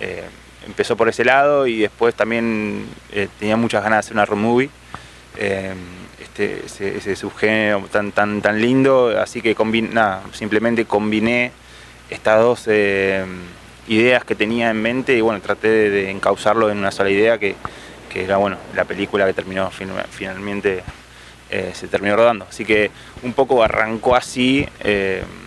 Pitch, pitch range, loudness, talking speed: 105 Hz, 100-115 Hz, -18 LUFS, 165 wpm